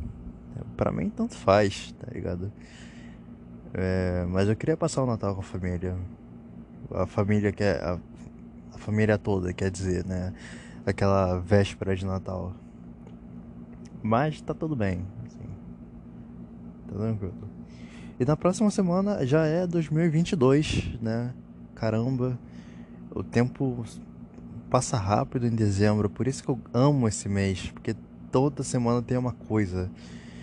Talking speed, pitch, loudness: 130 wpm, 100 Hz, -27 LUFS